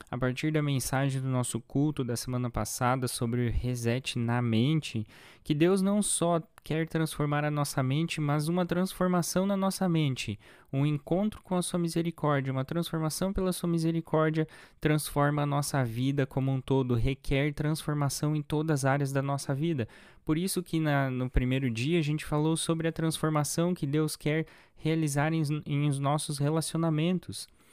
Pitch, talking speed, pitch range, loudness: 150 Hz, 170 wpm, 135-160 Hz, -30 LUFS